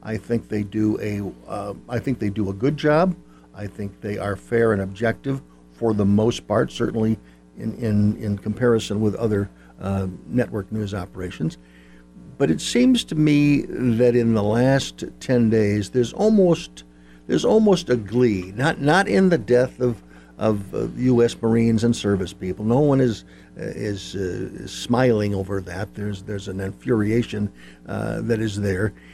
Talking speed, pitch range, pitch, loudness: 165 wpm, 95-120 Hz, 105 Hz, -22 LUFS